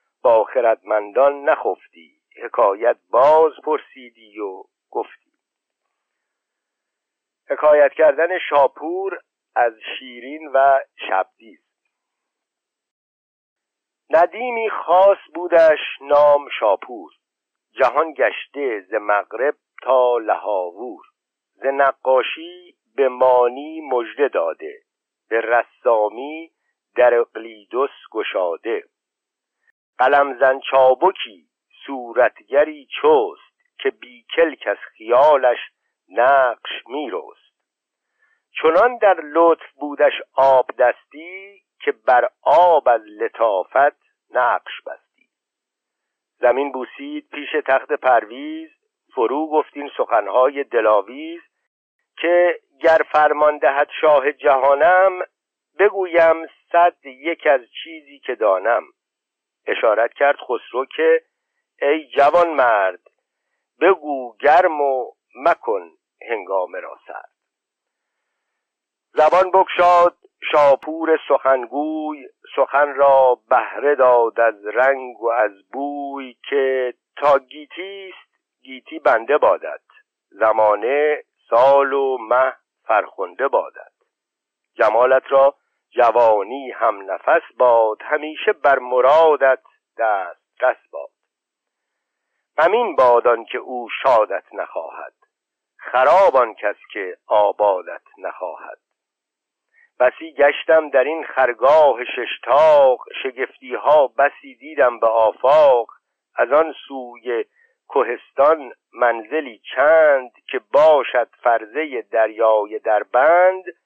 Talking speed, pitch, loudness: 90 wpm, 160 Hz, -17 LUFS